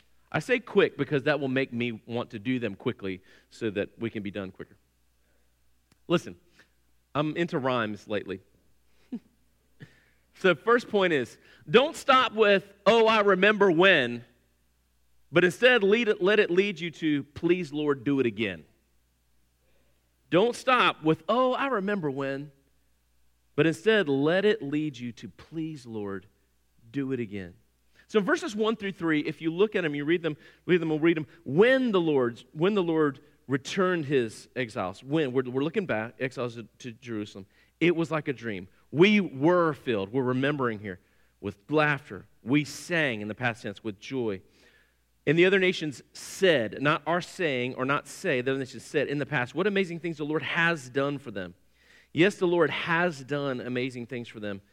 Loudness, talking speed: -26 LUFS, 180 wpm